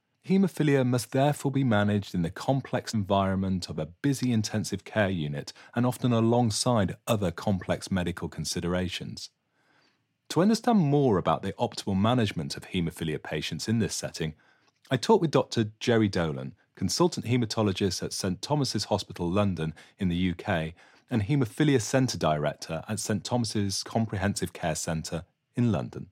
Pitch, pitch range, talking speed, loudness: 105 Hz, 90-125 Hz, 145 wpm, -28 LUFS